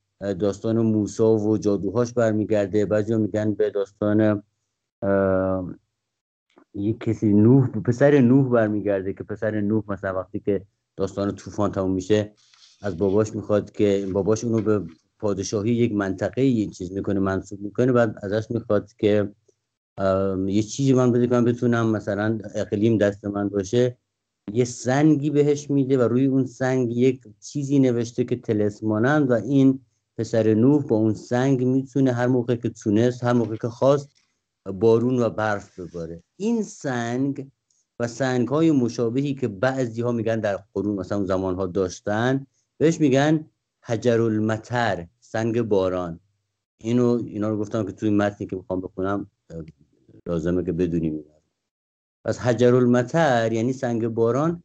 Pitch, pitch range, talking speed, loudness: 110 Hz, 100-125 Hz, 145 wpm, -22 LUFS